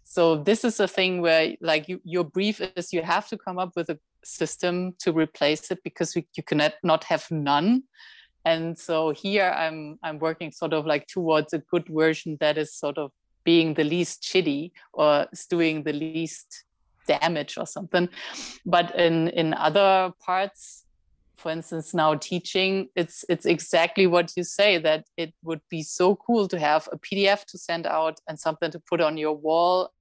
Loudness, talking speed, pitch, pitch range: -25 LUFS, 185 wpm, 170 Hz, 155-185 Hz